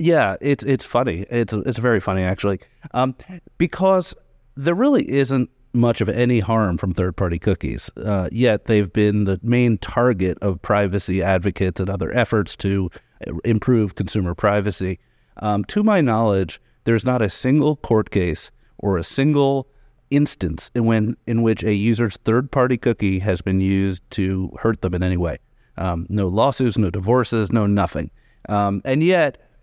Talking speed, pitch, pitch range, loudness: 160 wpm, 110 Hz, 95-125 Hz, -20 LUFS